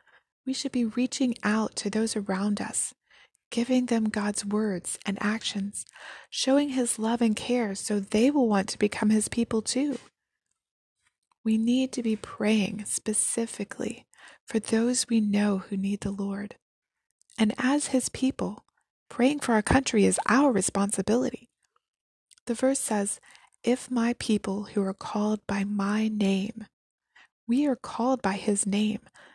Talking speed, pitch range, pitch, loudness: 145 wpm, 205-250 Hz, 220 Hz, -27 LUFS